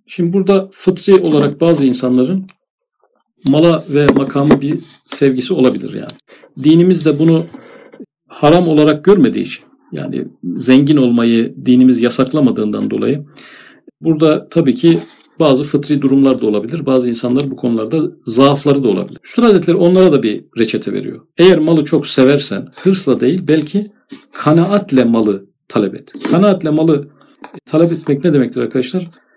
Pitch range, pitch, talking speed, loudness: 135-175 Hz, 150 Hz, 135 wpm, -13 LUFS